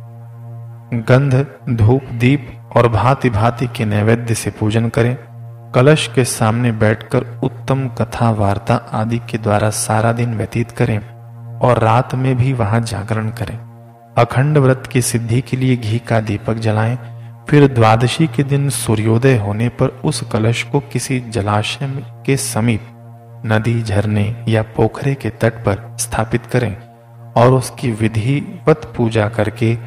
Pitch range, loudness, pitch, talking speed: 115-125 Hz, -16 LUFS, 115 Hz, 140 wpm